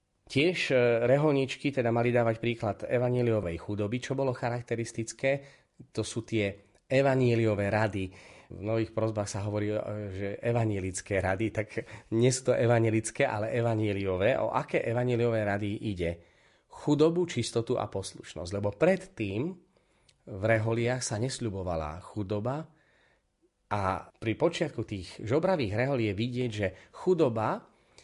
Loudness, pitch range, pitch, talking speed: -30 LUFS, 105-125 Hz, 115 Hz, 120 wpm